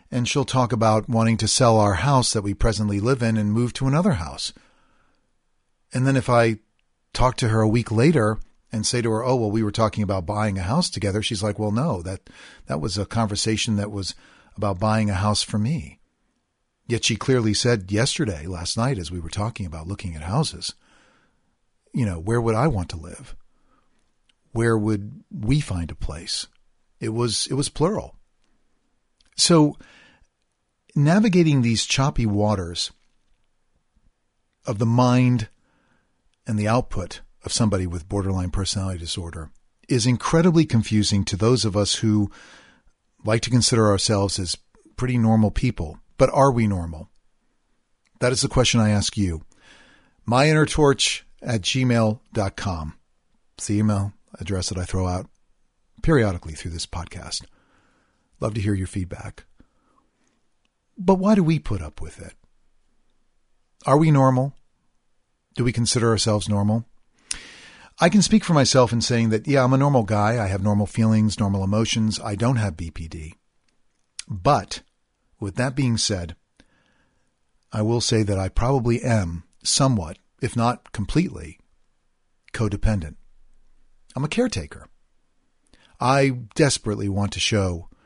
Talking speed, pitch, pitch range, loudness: 150 wpm, 110 Hz, 100-125 Hz, -22 LUFS